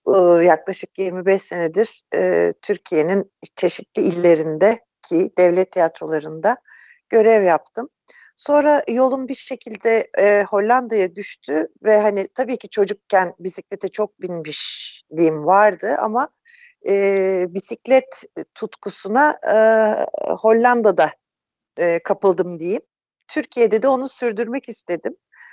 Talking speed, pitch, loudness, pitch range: 95 wpm, 205 Hz, -18 LUFS, 185-240 Hz